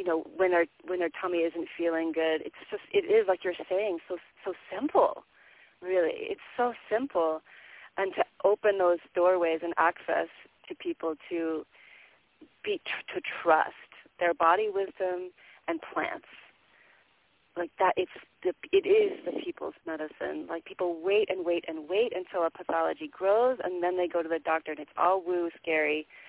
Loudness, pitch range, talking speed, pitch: -29 LUFS, 165-210 Hz, 170 wpm, 180 Hz